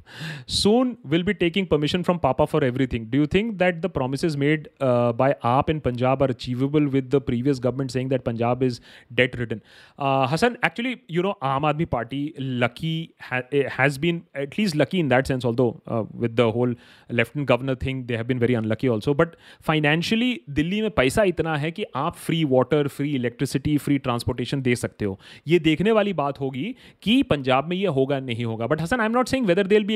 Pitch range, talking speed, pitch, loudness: 125-170 Hz, 205 wpm, 140 Hz, -23 LUFS